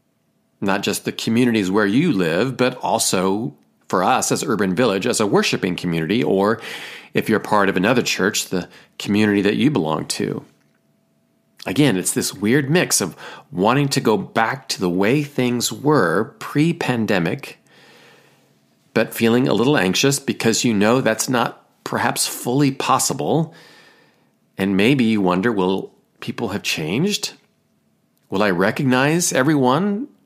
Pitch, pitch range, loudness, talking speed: 120 Hz, 105-140 Hz, -19 LUFS, 145 wpm